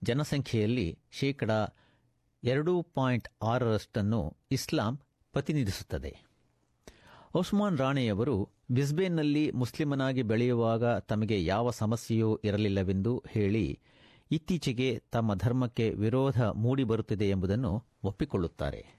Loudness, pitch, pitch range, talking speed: -31 LUFS, 120 Hz, 105-135 Hz, 75 wpm